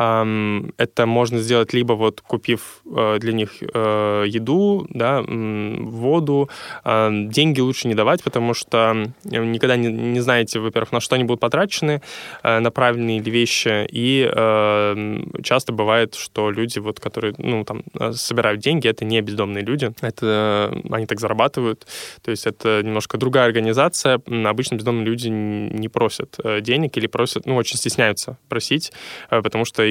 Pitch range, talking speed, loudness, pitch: 110-125 Hz, 140 wpm, -20 LUFS, 115 Hz